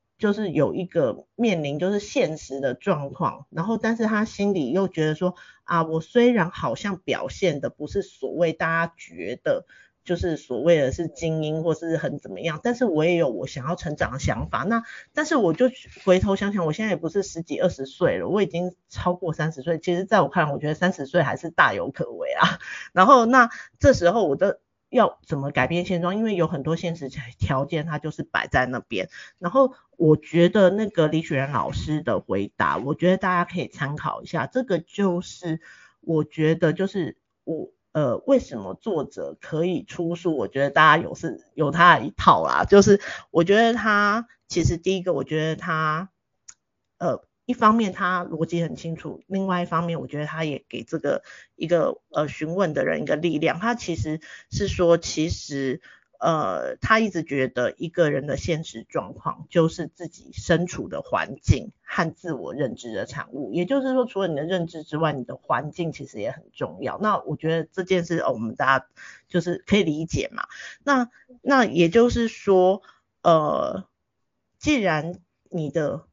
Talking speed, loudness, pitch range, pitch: 270 characters per minute, -23 LUFS, 155-195 Hz, 170 Hz